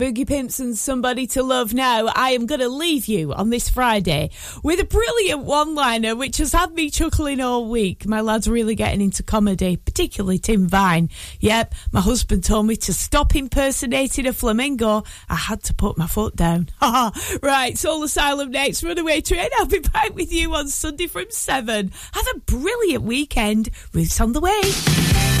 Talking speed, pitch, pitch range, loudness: 185 wpm, 255 Hz, 215-305 Hz, -20 LUFS